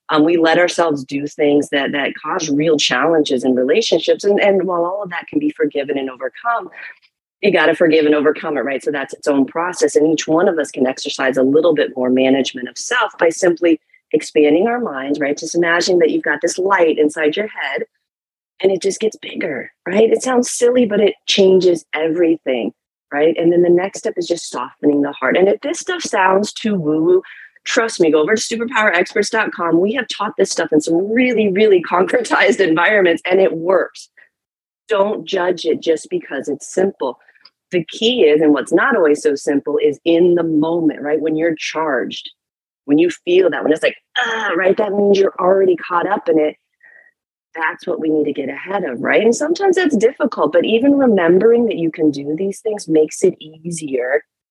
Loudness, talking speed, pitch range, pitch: -16 LUFS, 200 wpm, 155-215 Hz, 175 Hz